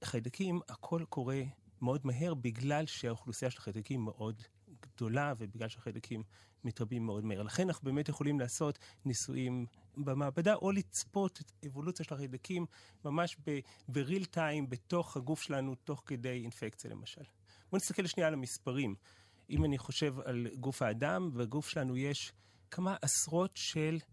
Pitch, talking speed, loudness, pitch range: 135 Hz, 140 wpm, -38 LUFS, 115-155 Hz